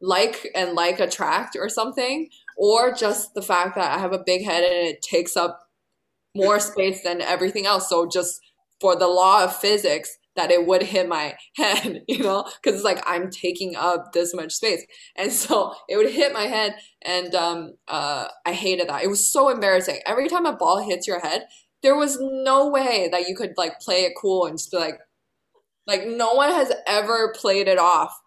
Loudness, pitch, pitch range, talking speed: -21 LUFS, 190 Hz, 175-230 Hz, 205 wpm